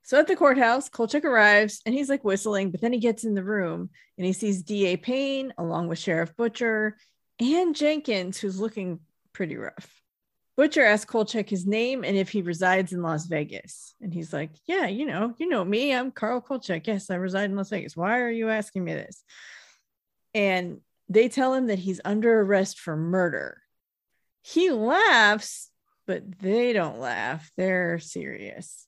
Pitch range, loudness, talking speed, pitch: 185-240 Hz, -25 LUFS, 180 wpm, 210 Hz